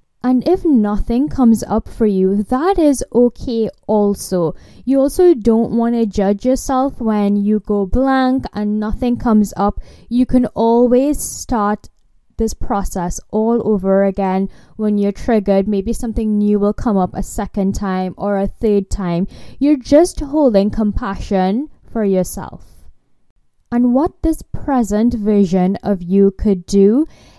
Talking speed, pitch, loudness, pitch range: 145 wpm, 215 Hz, -16 LUFS, 200-250 Hz